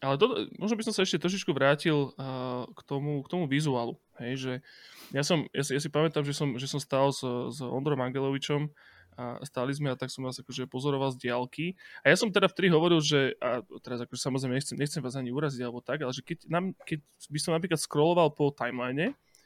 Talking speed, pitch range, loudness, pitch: 215 wpm, 130-160 Hz, -30 LUFS, 140 Hz